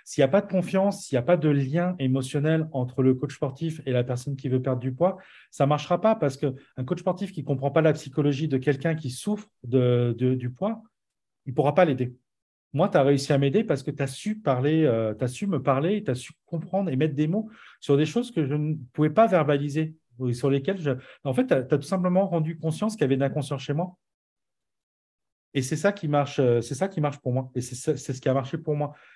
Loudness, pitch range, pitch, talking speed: -25 LUFS, 130-170 Hz, 145 Hz, 255 wpm